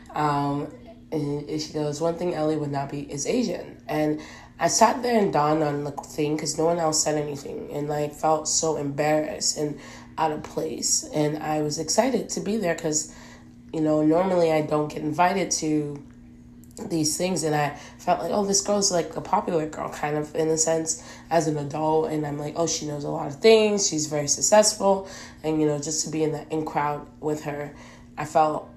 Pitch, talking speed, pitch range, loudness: 155 Hz, 210 wpm, 150-165 Hz, -24 LUFS